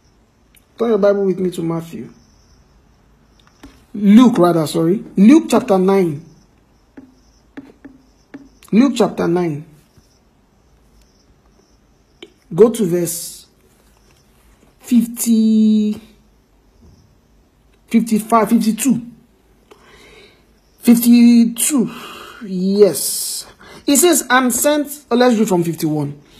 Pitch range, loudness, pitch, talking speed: 175-235 Hz, -14 LUFS, 215 Hz, 75 wpm